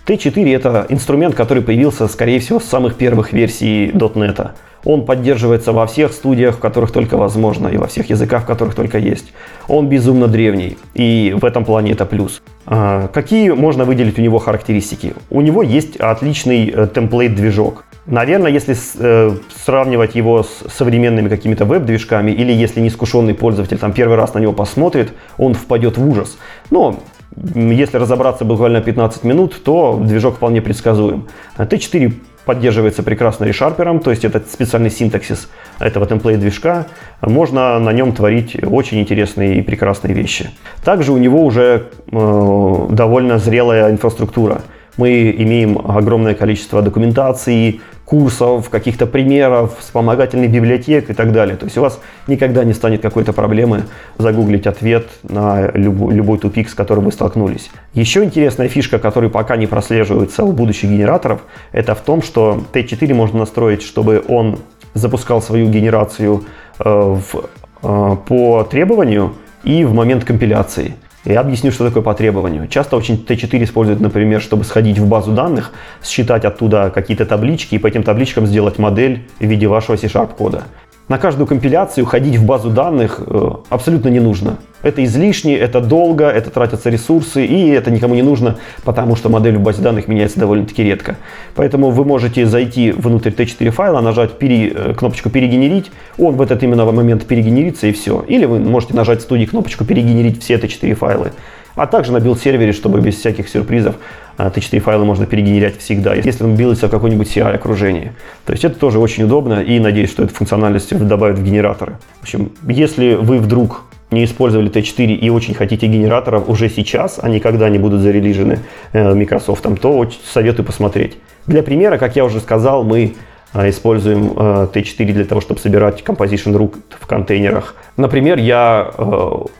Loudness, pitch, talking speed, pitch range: -13 LUFS, 115 Hz, 155 wpm, 105-125 Hz